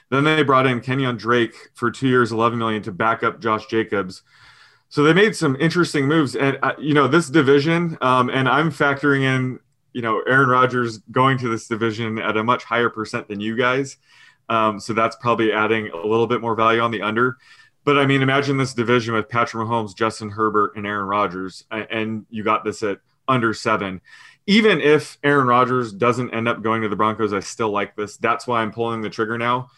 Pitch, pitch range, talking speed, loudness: 120 Hz, 110-135 Hz, 210 wpm, -19 LUFS